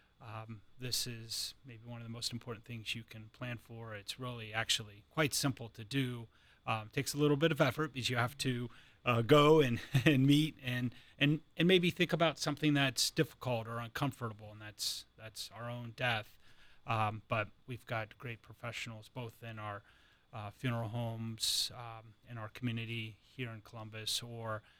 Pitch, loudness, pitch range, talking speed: 120 Hz, -35 LUFS, 110-130 Hz, 180 wpm